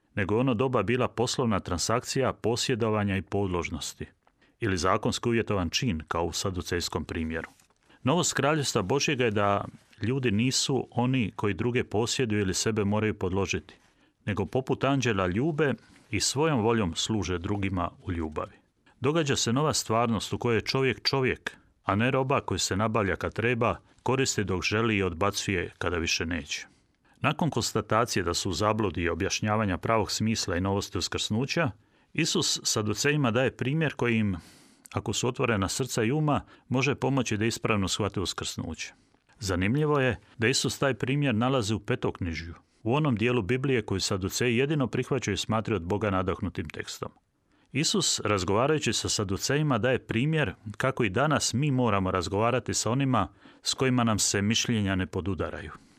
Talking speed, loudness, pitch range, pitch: 155 wpm, -27 LUFS, 100-130 Hz, 110 Hz